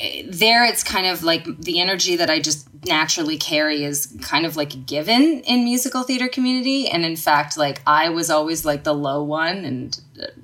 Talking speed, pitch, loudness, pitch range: 190 wpm, 160 Hz, -19 LUFS, 150-215 Hz